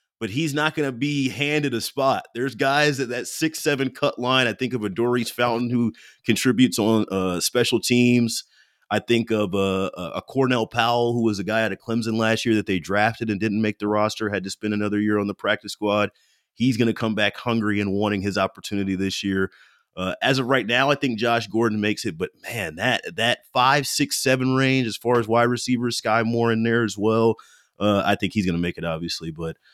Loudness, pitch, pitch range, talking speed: -22 LUFS, 115 Hz, 105-125 Hz, 230 wpm